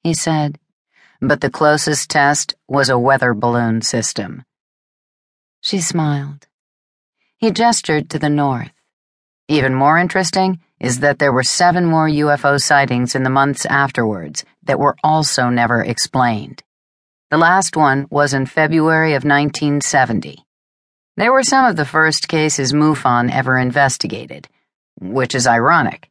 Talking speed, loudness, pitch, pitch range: 135 wpm, -15 LUFS, 140 Hz, 125-155 Hz